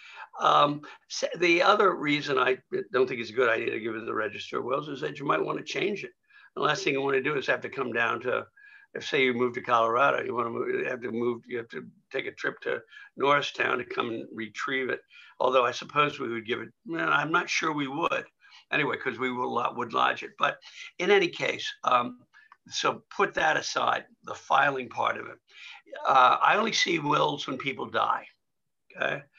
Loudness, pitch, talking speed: -27 LUFS, 175 Hz, 225 wpm